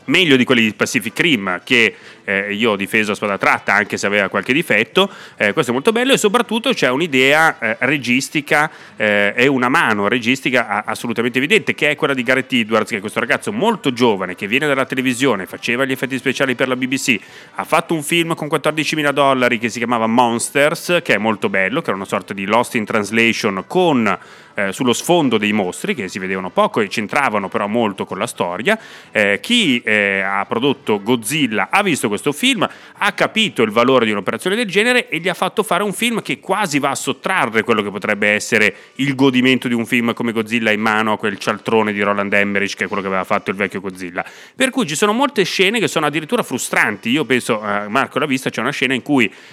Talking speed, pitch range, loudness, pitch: 215 wpm, 110-160 Hz, -16 LUFS, 130 Hz